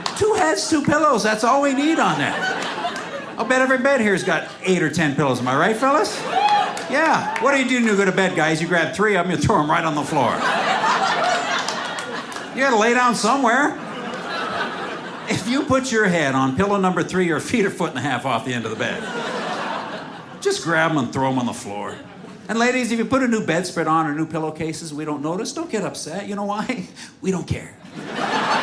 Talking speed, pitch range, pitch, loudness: 225 wpm, 160-255 Hz, 205 Hz, -20 LUFS